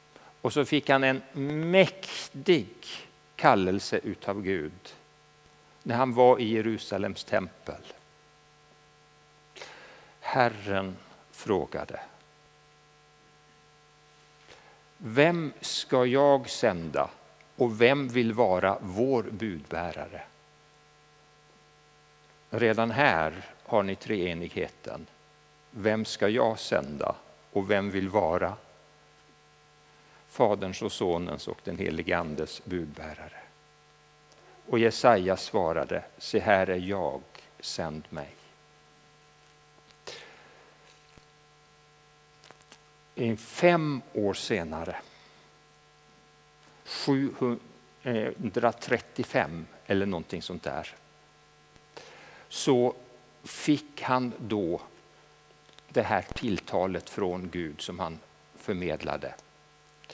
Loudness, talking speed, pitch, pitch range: -28 LUFS, 80 wpm, 75 Hz, 75-105 Hz